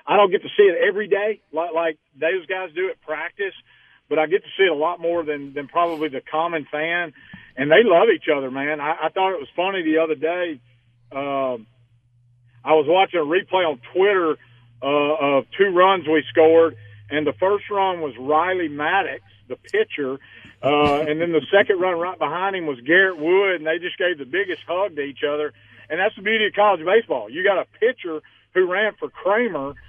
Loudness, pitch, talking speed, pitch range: -20 LUFS, 160 Hz, 210 wpm, 145-190 Hz